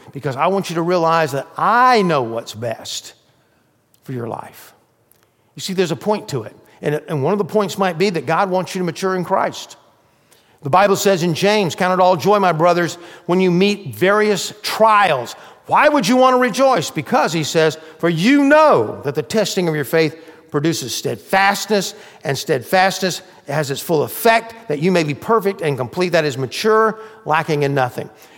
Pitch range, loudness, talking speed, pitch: 155-205 Hz, -17 LUFS, 195 wpm, 185 Hz